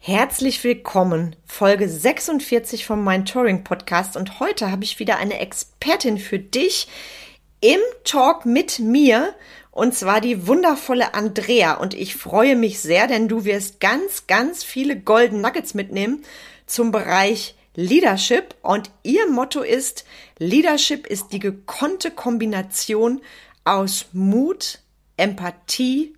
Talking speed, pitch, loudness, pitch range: 125 wpm, 230 Hz, -19 LUFS, 200-270 Hz